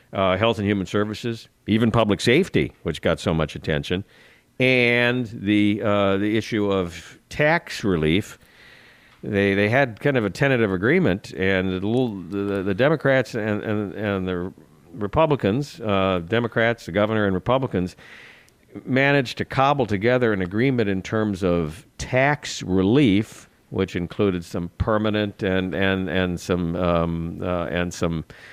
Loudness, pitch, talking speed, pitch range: -22 LUFS, 105 Hz, 145 wpm, 95-115 Hz